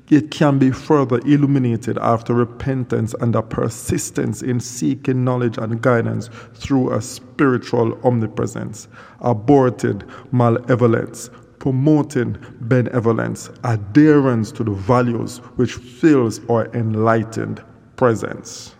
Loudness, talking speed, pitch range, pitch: -18 LUFS, 100 wpm, 115-130 Hz, 120 Hz